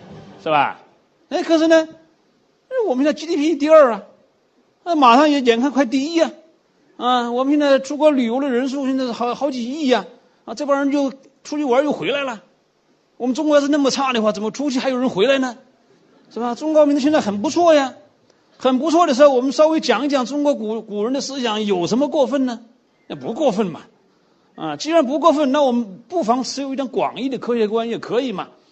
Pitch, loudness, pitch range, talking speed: 275 Hz, -18 LUFS, 245-300 Hz, 305 characters per minute